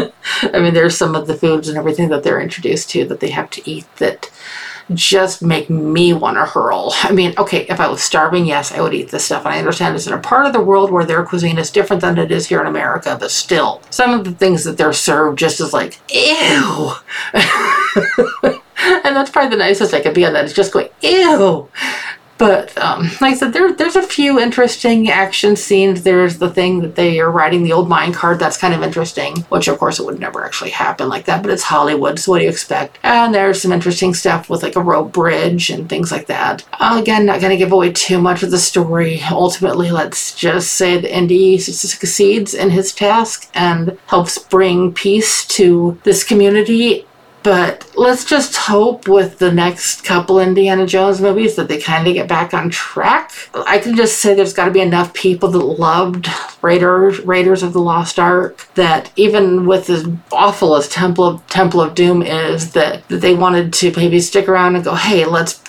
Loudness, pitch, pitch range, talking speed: -13 LUFS, 185 Hz, 170-200 Hz, 210 wpm